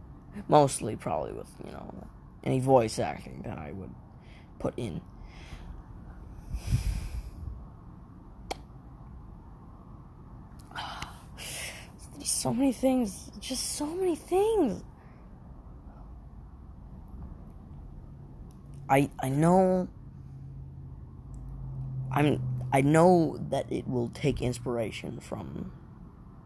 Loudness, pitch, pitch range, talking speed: -29 LUFS, 130 Hz, 115-180 Hz, 75 wpm